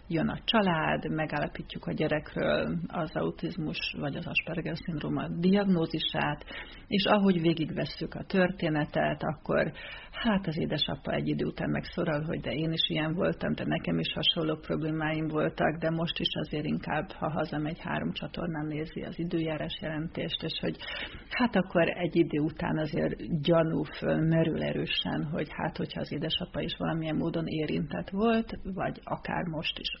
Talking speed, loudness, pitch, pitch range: 155 wpm, -30 LUFS, 165 Hz, 155-180 Hz